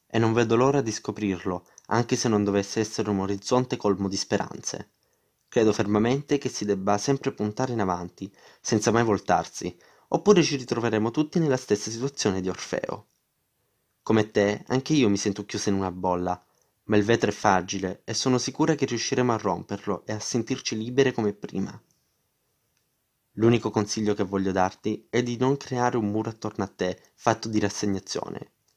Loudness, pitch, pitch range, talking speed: -26 LUFS, 110 Hz, 100-125 Hz, 170 wpm